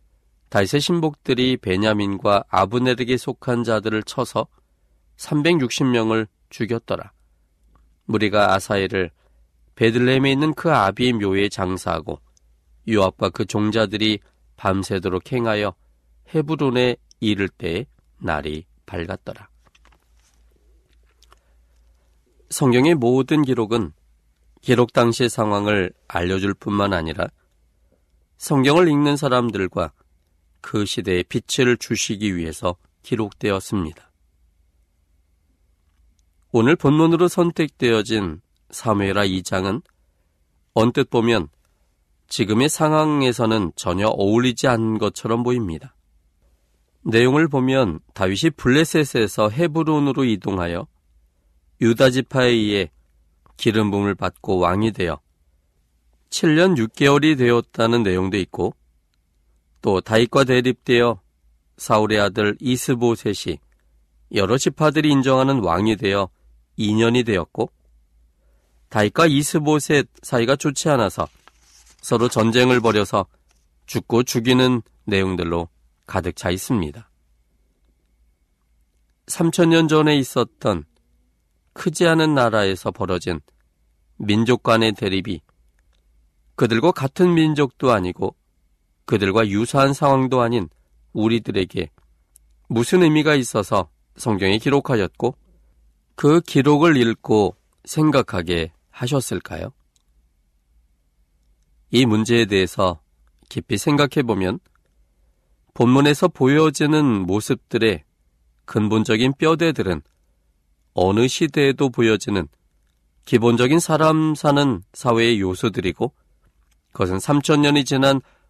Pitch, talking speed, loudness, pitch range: 100 Hz, 230 characters per minute, -19 LUFS, 75-125 Hz